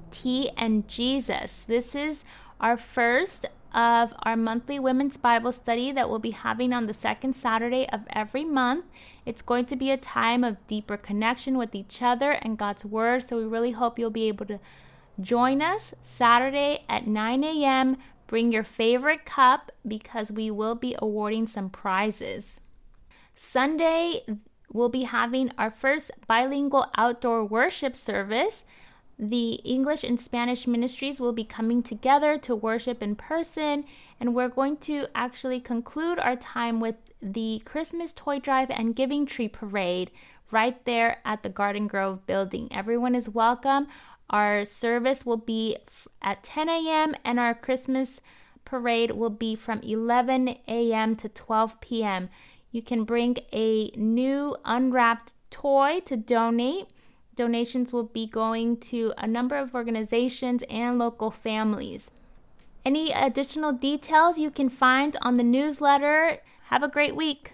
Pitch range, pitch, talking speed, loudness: 225-270 Hz, 240 Hz, 150 wpm, -26 LUFS